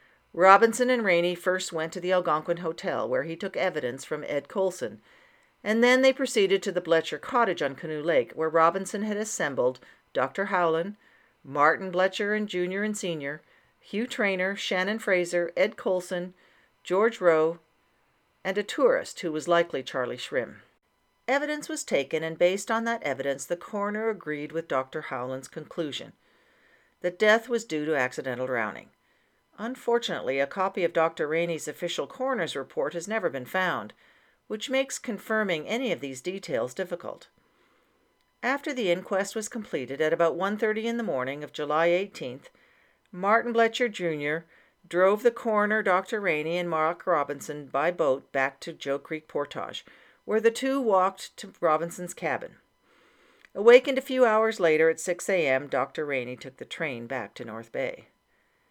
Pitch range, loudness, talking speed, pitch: 160-220 Hz, -27 LUFS, 160 wpm, 185 Hz